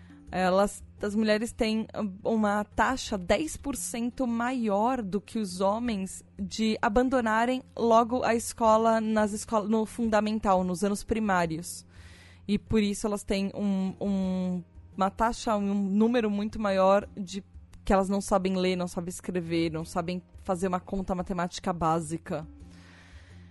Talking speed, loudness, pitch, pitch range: 135 wpm, -28 LUFS, 200 Hz, 185-220 Hz